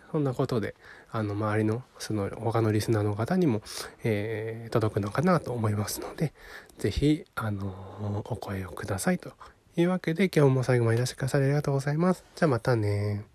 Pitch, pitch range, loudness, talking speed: 115 Hz, 105-145 Hz, -28 LUFS, 385 characters per minute